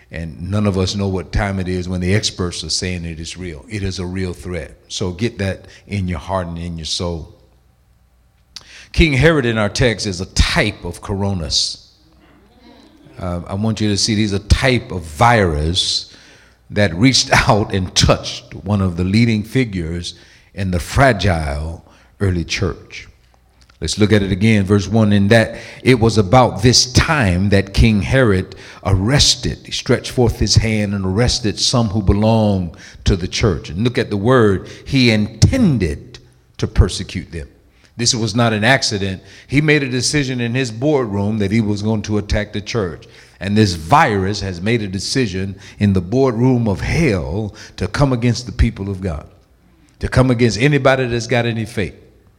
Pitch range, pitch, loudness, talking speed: 95-115 Hz, 100 Hz, -16 LUFS, 180 wpm